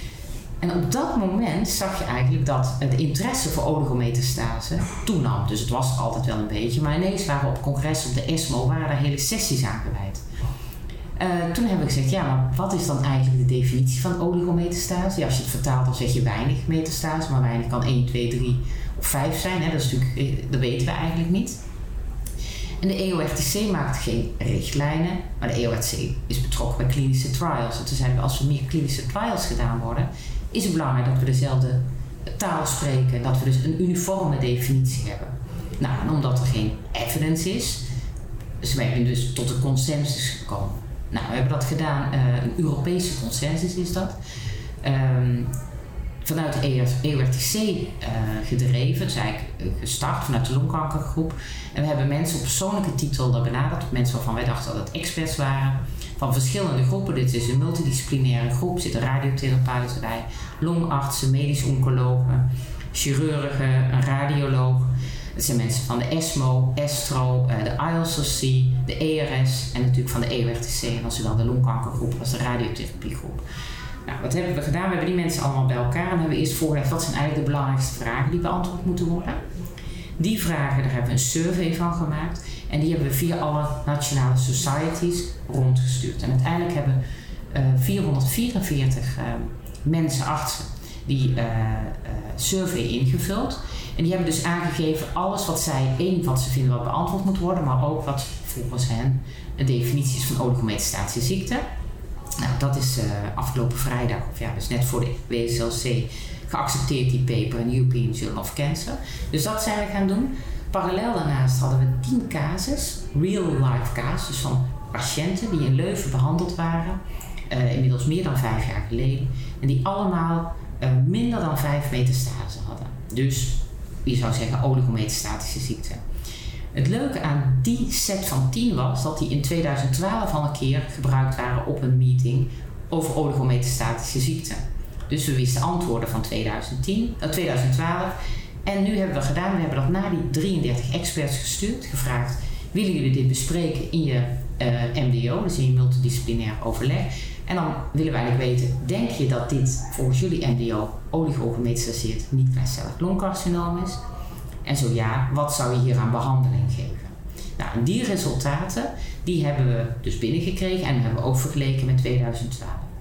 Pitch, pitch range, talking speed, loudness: 130 Hz, 125-155 Hz, 170 wpm, -24 LUFS